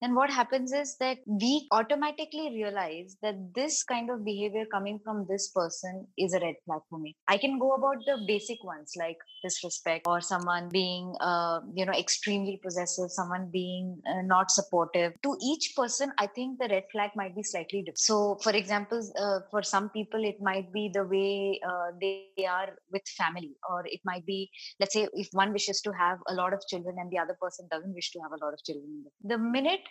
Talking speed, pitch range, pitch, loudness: 205 wpm, 180-220 Hz, 195 Hz, -31 LUFS